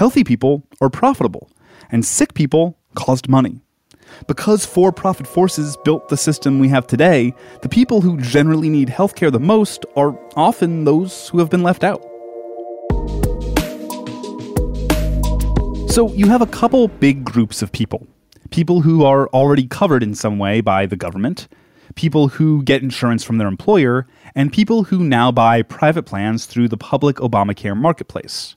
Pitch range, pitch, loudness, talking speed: 115-170 Hz, 140 Hz, -16 LUFS, 155 wpm